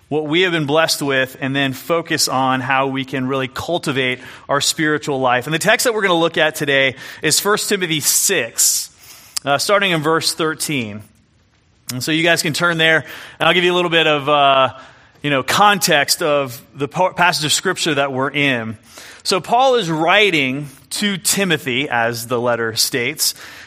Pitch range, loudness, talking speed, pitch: 130-165 Hz, -16 LUFS, 190 wpm, 145 Hz